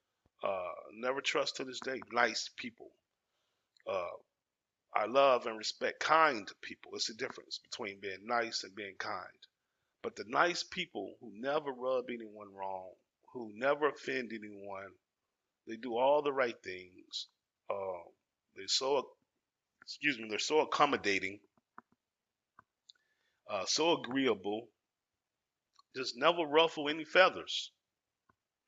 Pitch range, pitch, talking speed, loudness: 100-135 Hz, 120 Hz, 125 wpm, -34 LUFS